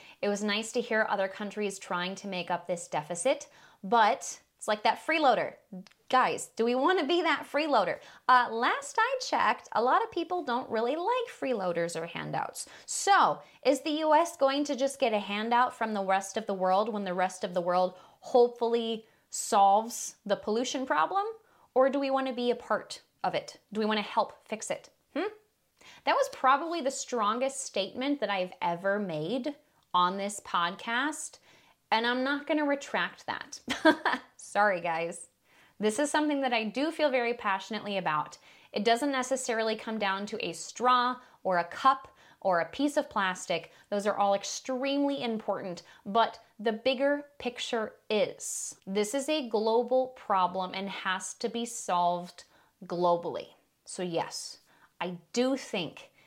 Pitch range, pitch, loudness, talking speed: 195-275 Hz, 230 Hz, -30 LUFS, 165 wpm